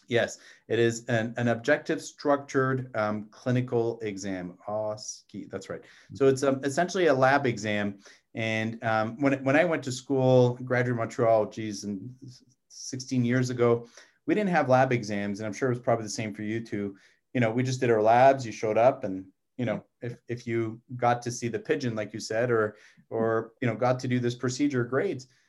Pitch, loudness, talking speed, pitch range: 120 Hz, -27 LUFS, 205 wpm, 110-130 Hz